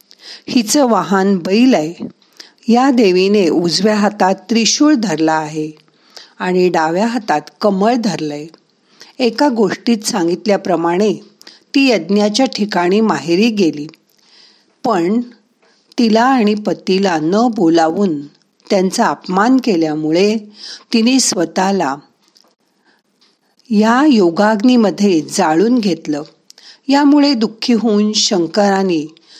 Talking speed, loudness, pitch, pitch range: 90 wpm, -14 LUFS, 205 Hz, 170-230 Hz